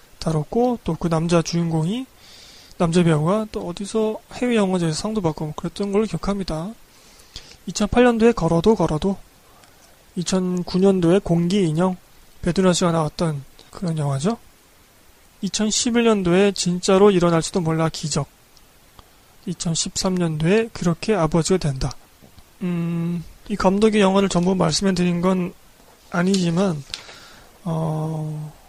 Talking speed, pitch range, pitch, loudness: 245 characters per minute, 160-200 Hz, 175 Hz, -20 LUFS